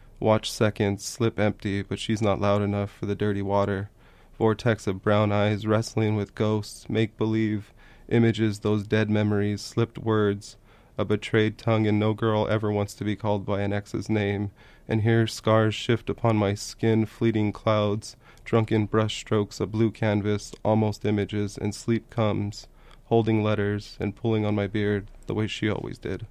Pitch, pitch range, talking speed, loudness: 105 Hz, 105-110 Hz, 170 wpm, -26 LUFS